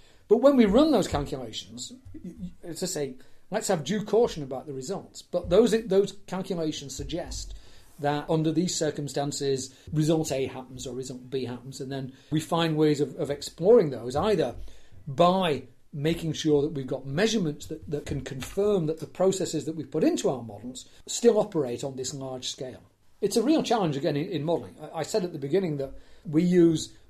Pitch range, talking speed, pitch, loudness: 135-180 Hz, 190 wpm, 150 Hz, -27 LUFS